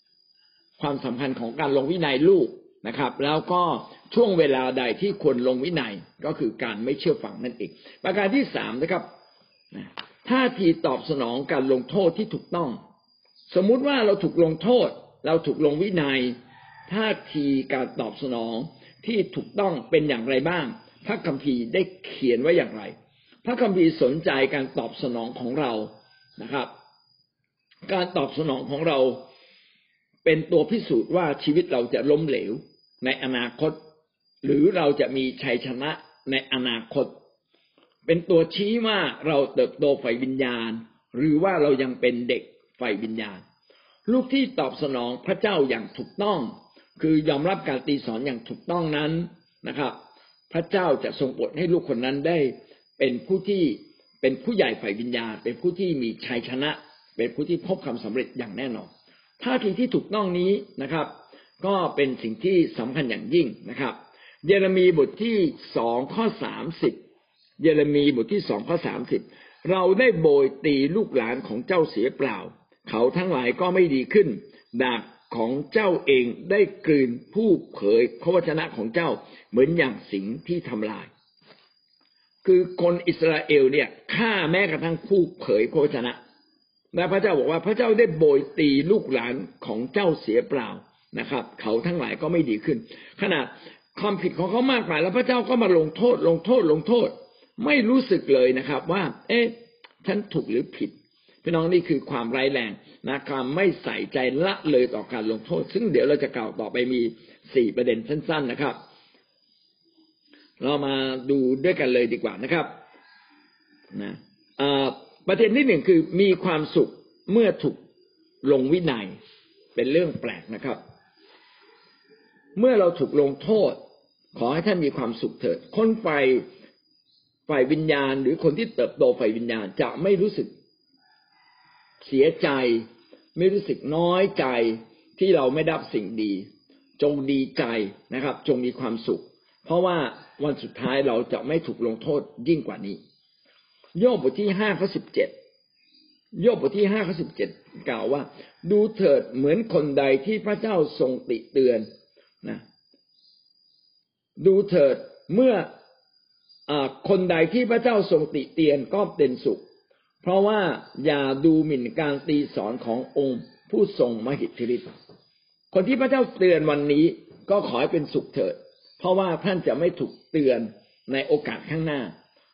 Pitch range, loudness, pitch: 135-220 Hz, -24 LUFS, 170 Hz